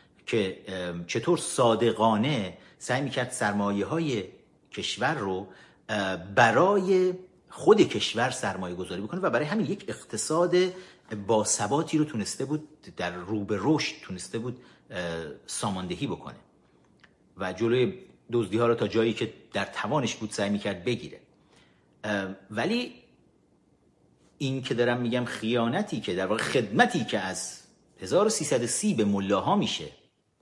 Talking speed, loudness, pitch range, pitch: 120 wpm, -27 LUFS, 100-130 Hz, 115 Hz